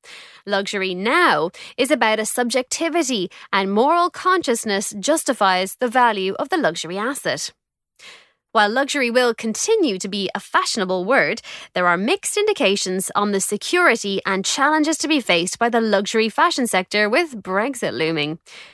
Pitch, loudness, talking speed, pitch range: 220 Hz, -19 LUFS, 145 wpm, 195-280 Hz